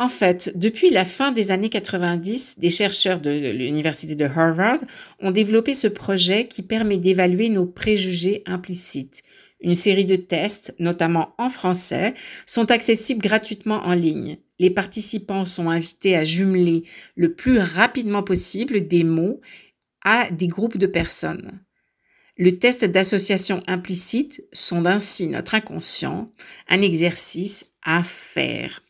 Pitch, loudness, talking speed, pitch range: 190 Hz, -20 LUFS, 135 wpm, 175-220 Hz